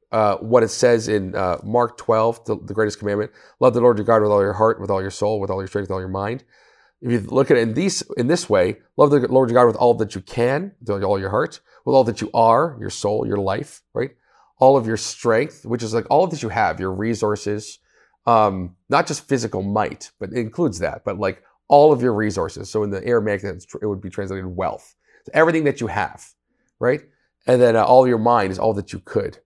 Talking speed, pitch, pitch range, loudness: 250 wpm, 110 Hz, 100-120 Hz, -19 LUFS